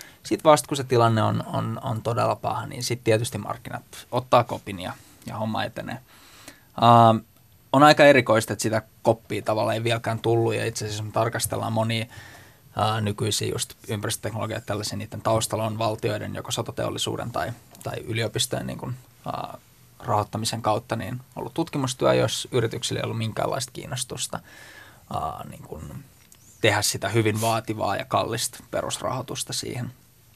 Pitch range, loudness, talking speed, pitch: 110-125 Hz, -24 LUFS, 145 wpm, 115 Hz